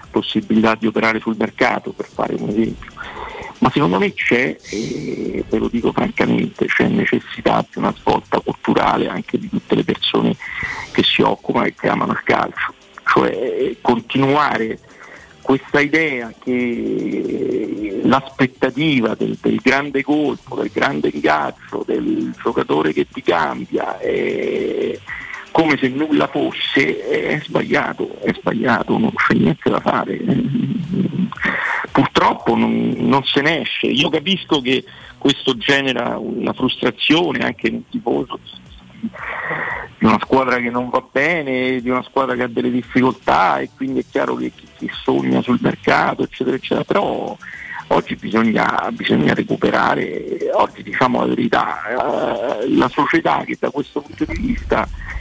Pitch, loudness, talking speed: 140 Hz, -18 LUFS, 140 wpm